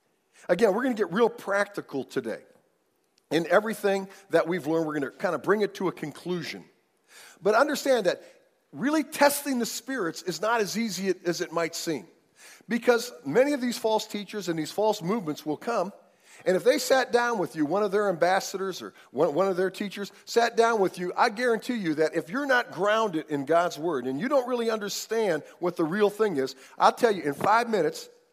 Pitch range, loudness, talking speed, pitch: 175-240 Hz, -26 LUFS, 205 wpm, 205 Hz